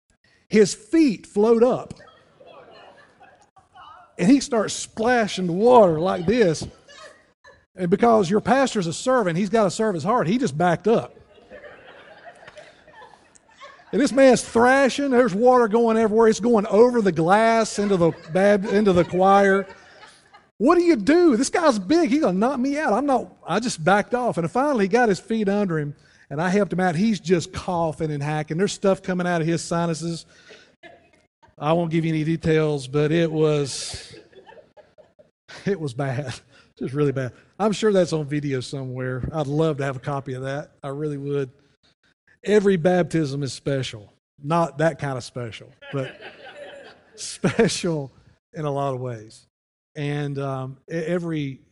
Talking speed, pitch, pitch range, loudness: 165 wpm, 180 Hz, 150-220 Hz, -21 LUFS